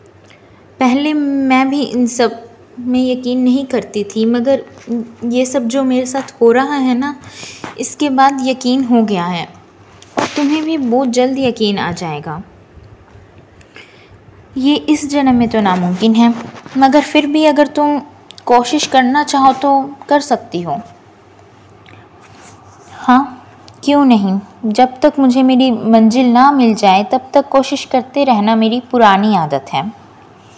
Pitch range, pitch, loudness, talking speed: 230-275 Hz, 255 Hz, -13 LUFS, 140 wpm